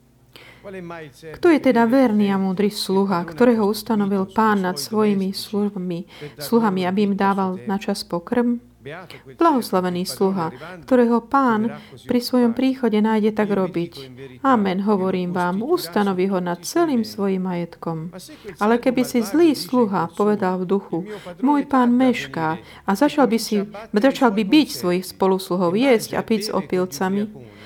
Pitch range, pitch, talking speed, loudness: 180-235 Hz, 200 Hz, 135 wpm, -20 LUFS